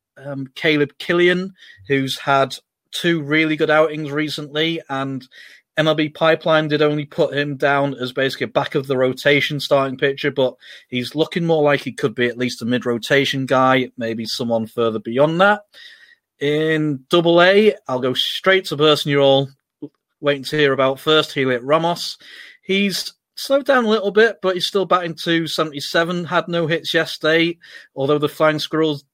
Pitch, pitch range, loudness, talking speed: 150 Hz, 135-170 Hz, -18 LUFS, 170 wpm